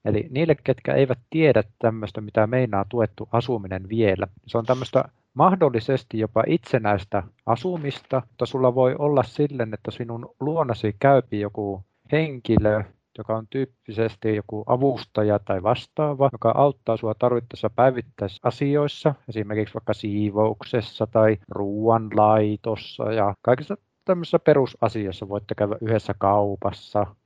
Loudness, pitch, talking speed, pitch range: -23 LUFS, 115 Hz, 120 wpm, 105-130 Hz